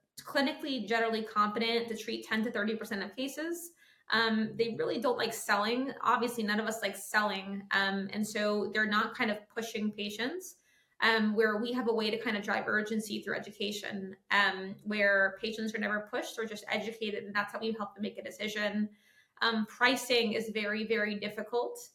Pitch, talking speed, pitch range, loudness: 215 Hz, 190 wpm, 210-230 Hz, -32 LUFS